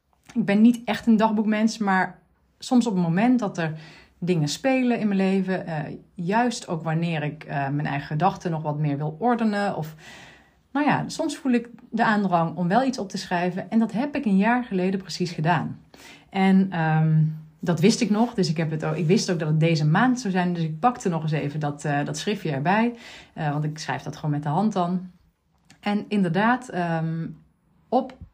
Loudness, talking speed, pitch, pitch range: -24 LUFS, 210 wpm, 185 Hz, 160-220 Hz